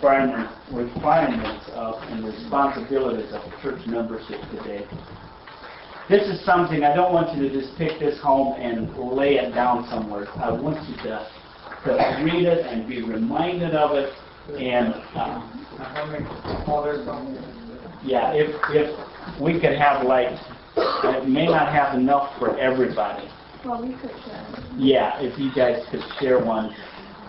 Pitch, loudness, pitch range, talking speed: 135 Hz, -23 LUFS, 120-150 Hz, 130 wpm